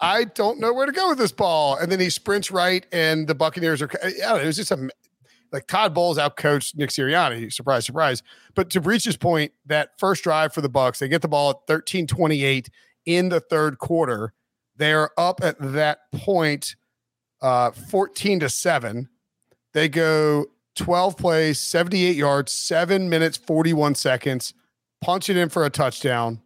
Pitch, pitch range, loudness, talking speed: 160 Hz, 140-180 Hz, -21 LUFS, 180 wpm